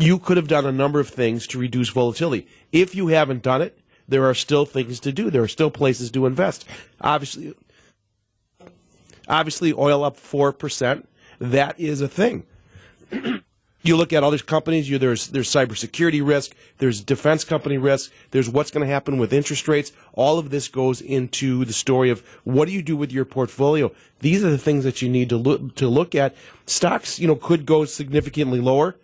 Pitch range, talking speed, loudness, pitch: 130-155 Hz, 195 wpm, -21 LUFS, 140 Hz